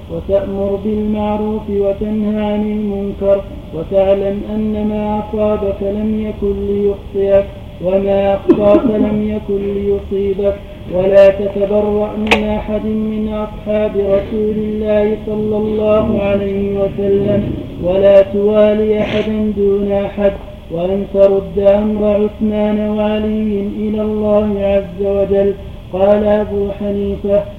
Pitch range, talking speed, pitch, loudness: 200-215 Hz, 100 wpm, 205 Hz, -15 LUFS